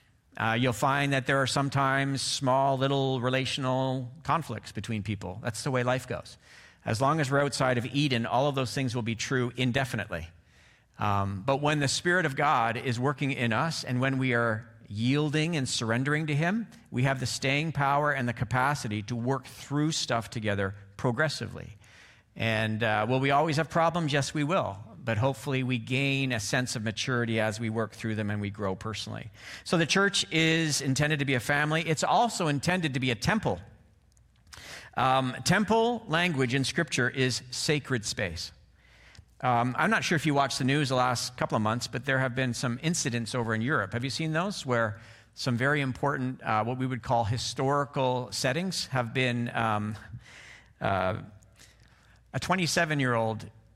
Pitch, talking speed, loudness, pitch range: 130 Hz, 185 wpm, -28 LUFS, 115-145 Hz